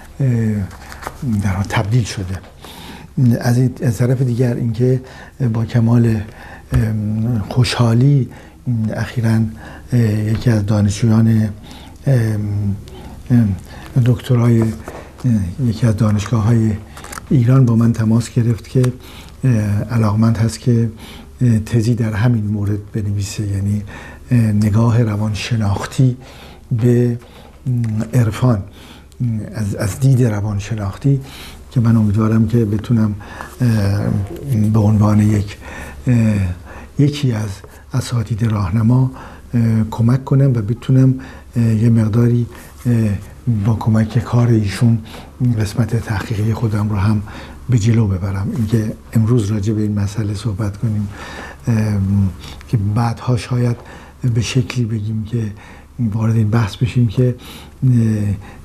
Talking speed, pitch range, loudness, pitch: 95 wpm, 105-120 Hz, -17 LUFS, 110 Hz